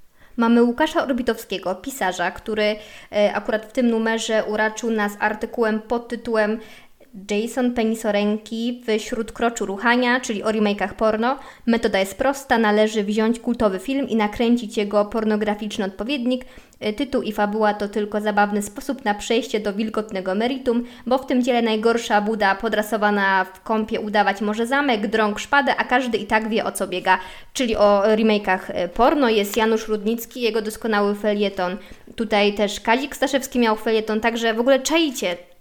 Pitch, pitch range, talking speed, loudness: 220 Hz, 210-235 Hz, 150 wpm, -21 LUFS